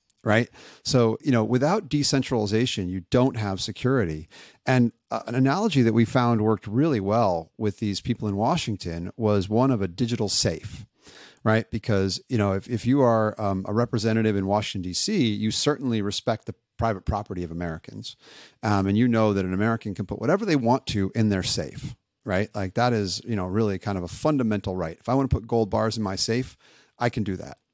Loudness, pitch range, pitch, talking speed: -24 LUFS, 100-120 Hz, 110 Hz, 205 wpm